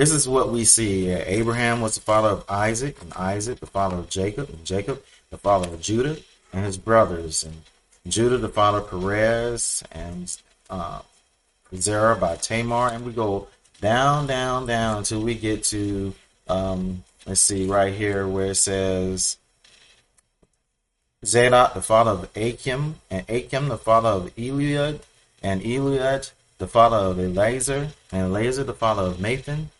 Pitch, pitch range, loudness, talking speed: 110 Hz, 95-120 Hz, -22 LUFS, 155 wpm